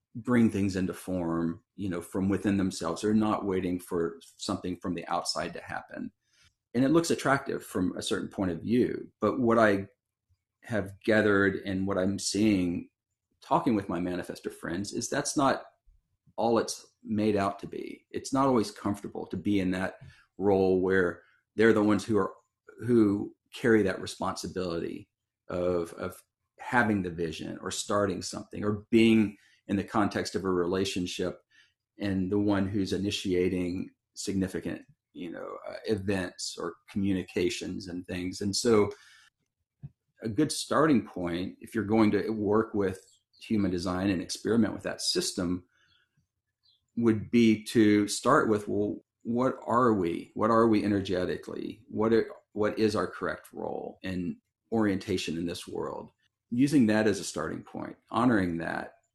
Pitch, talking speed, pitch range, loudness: 100 Hz, 155 wpm, 90-110 Hz, -29 LUFS